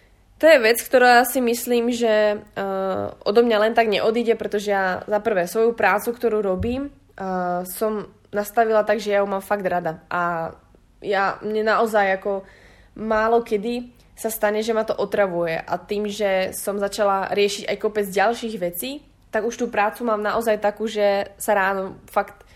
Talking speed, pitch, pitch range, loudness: 175 wpm, 210 Hz, 195-225 Hz, -21 LUFS